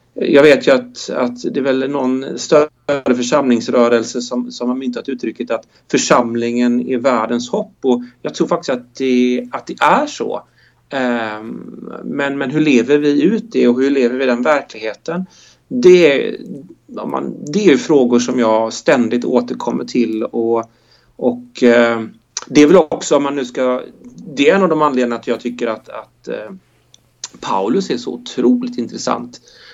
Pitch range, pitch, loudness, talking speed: 120-140 Hz, 125 Hz, -15 LUFS, 165 wpm